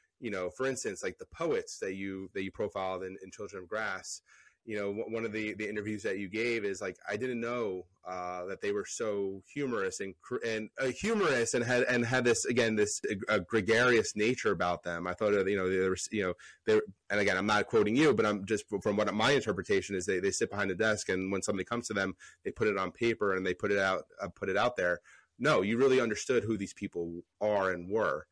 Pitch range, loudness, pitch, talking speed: 95-115 Hz, -32 LUFS, 105 Hz, 250 wpm